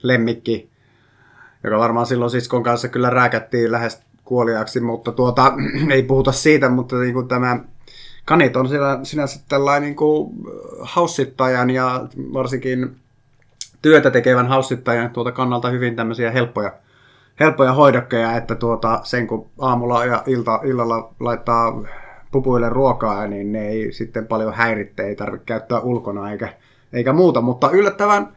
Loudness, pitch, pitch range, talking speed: -18 LUFS, 125 Hz, 115-135 Hz, 135 wpm